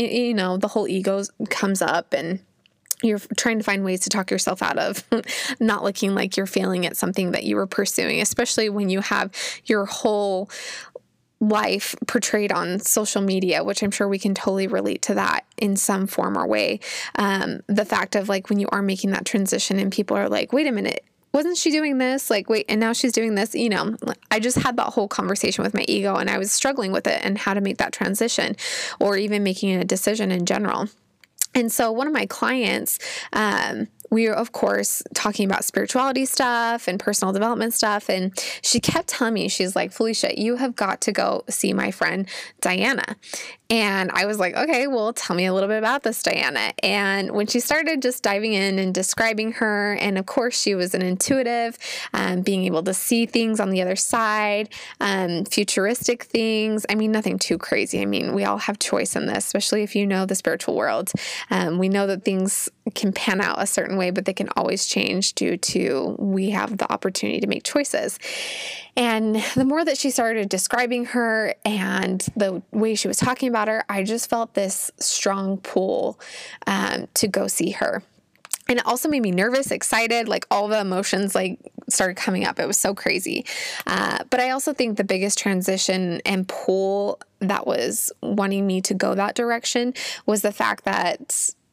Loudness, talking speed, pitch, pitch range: -22 LUFS, 200 wpm, 210 Hz, 195-235 Hz